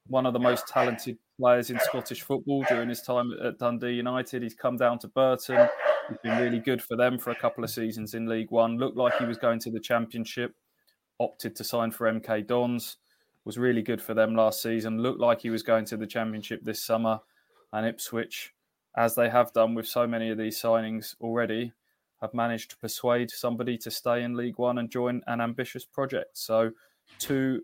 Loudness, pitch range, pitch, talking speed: -28 LUFS, 115-125 Hz, 120 Hz, 205 wpm